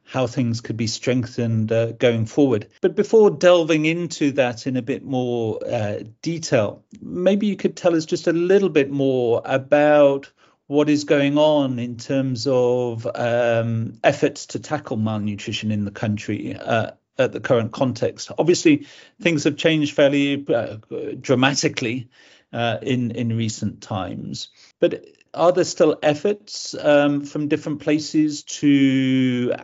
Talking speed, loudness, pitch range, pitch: 145 wpm, -20 LUFS, 120-155 Hz, 135 Hz